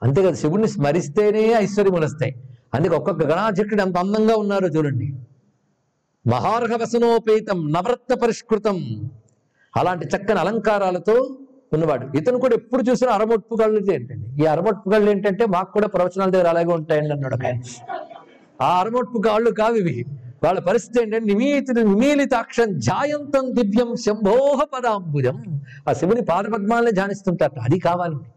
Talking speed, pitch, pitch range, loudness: 115 wpm, 200 Hz, 155-230 Hz, -20 LUFS